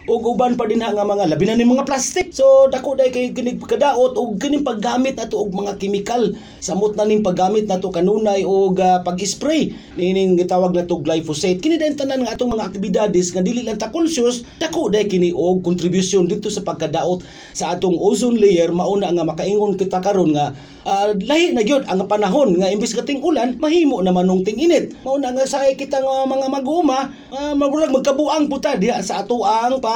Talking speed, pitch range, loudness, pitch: 200 wpm, 185-265 Hz, -18 LUFS, 215 Hz